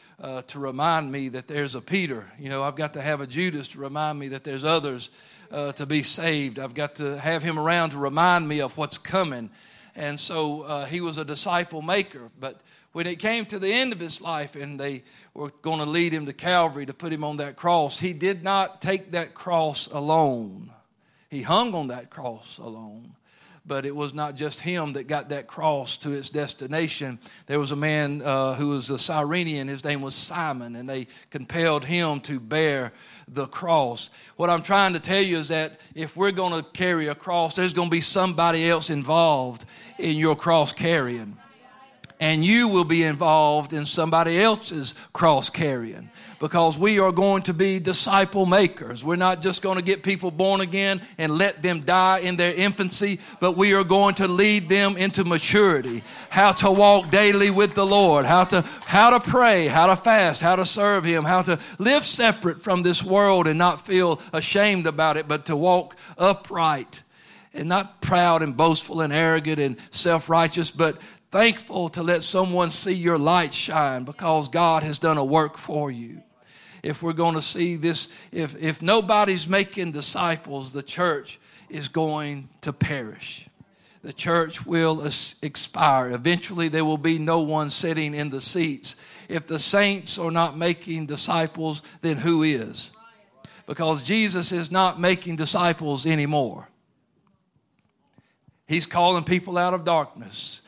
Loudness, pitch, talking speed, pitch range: -22 LUFS, 165 Hz, 180 wpm, 150-185 Hz